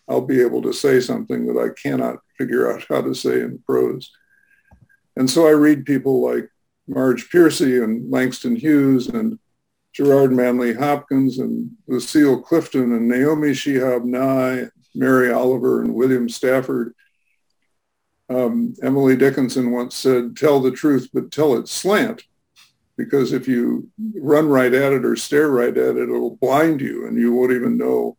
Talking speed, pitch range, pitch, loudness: 160 wpm, 125-150 Hz, 130 Hz, -18 LUFS